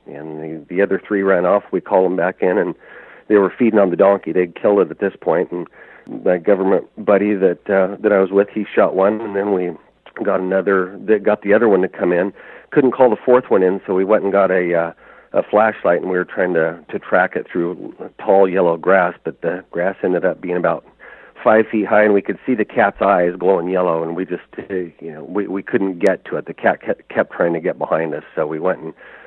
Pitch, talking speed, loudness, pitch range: 95 Hz, 250 wpm, -17 LUFS, 90-100 Hz